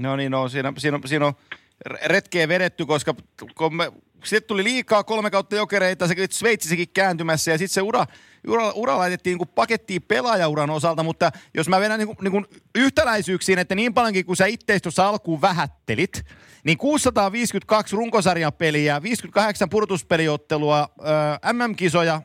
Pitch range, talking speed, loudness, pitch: 160-210 Hz, 150 wpm, -21 LUFS, 185 Hz